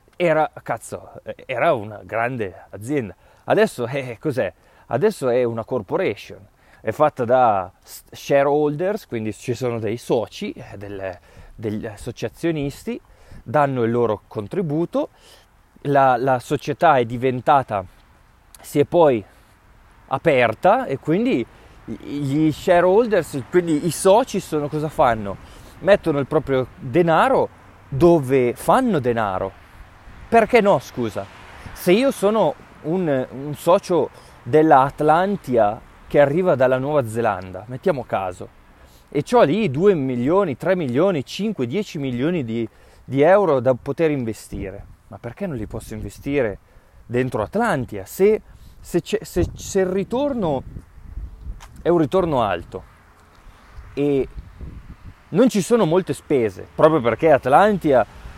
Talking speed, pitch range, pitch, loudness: 120 wpm, 110-170 Hz, 135 Hz, -20 LUFS